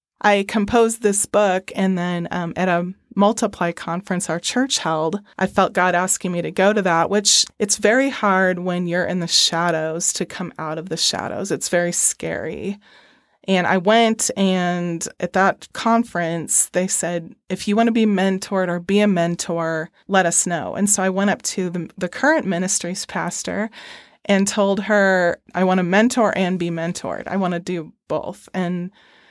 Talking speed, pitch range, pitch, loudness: 185 wpm, 175-205 Hz, 185 Hz, -19 LUFS